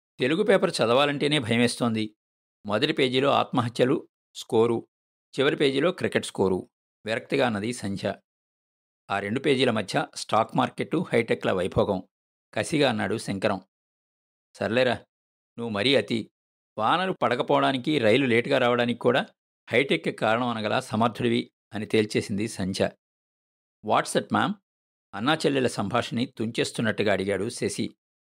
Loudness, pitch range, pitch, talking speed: -25 LUFS, 95-120 Hz, 110 Hz, 105 wpm